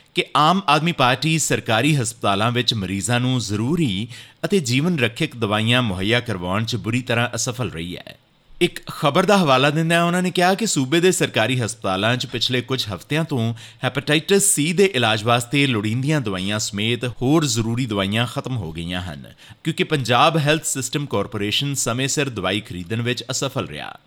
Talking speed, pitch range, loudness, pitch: 170 wpm, 110-150 Hz, -20 LUFS, 125 Hz